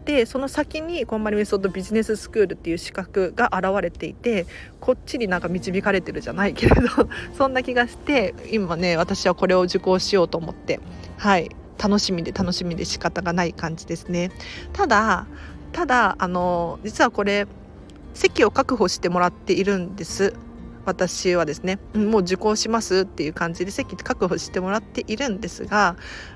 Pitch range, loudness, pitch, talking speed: 180-230 Hz, -22 LUFS, 195 Hz, 355 characters per minute